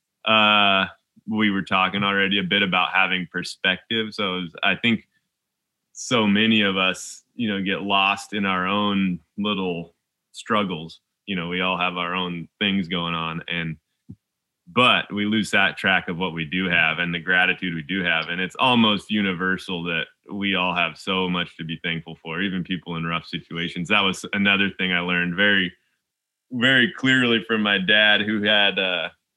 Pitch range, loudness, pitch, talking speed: 85-100 Hz, -21 LUFS, 95 Hz, 180 wpm